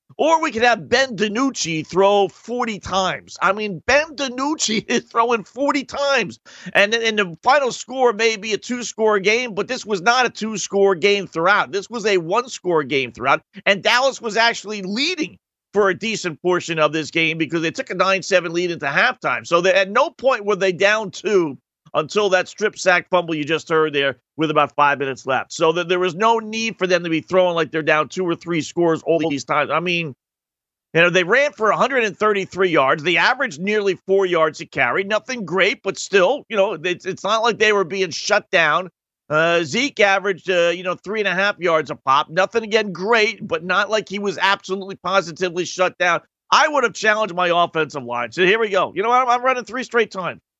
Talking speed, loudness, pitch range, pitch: 220 wpm, -19 LUFS, 170-225 Hz, 195 Hz